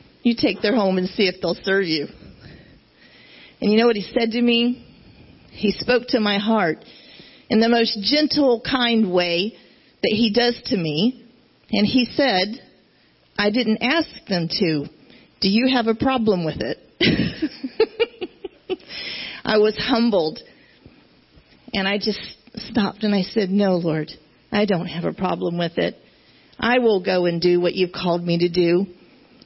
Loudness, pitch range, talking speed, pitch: -20 LUFS, 185-245 Hz, 160 wpm, 215 Hz